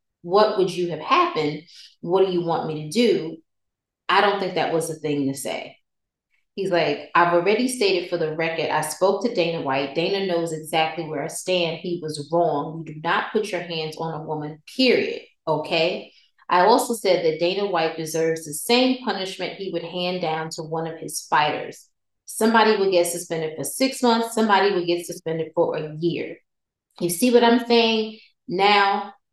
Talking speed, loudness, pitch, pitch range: 190 wpm, -22 LUFS, 175 Hz, 160-200 Hz